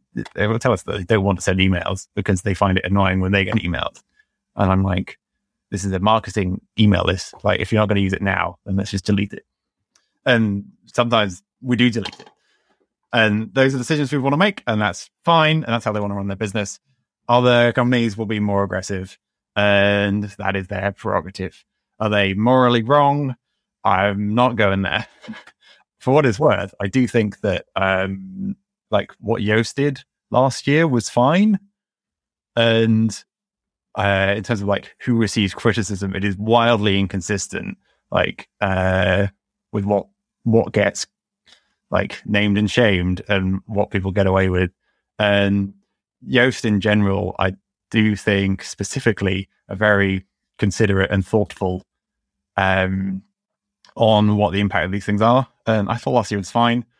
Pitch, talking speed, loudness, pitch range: 105 Hz, 175 wpm, -19 LUFS, 100-120 Hz